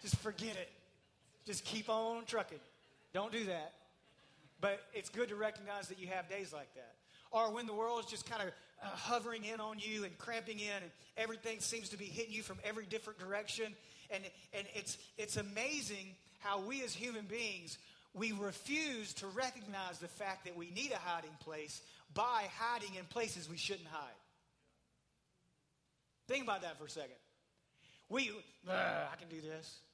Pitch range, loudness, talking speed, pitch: 175-225 Hz, -43 LUFS, 175 wpm, 205 Hz